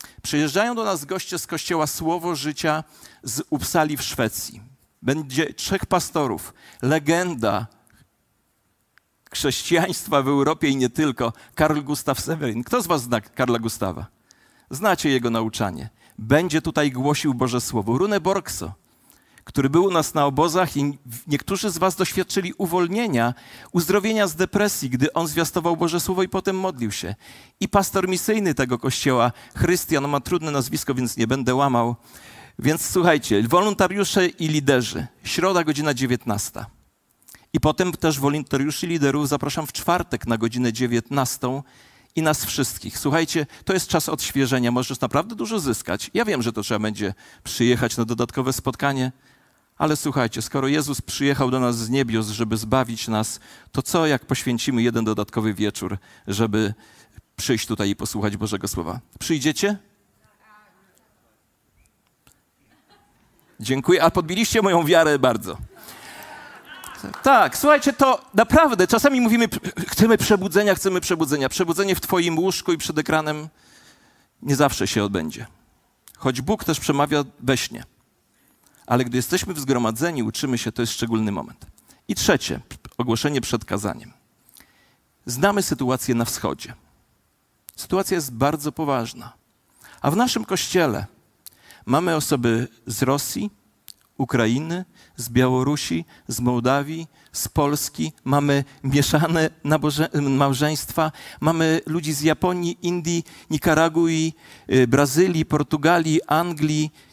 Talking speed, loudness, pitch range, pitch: 130 wpm, -22 LUFS, 120-170 Hz, 145 Hz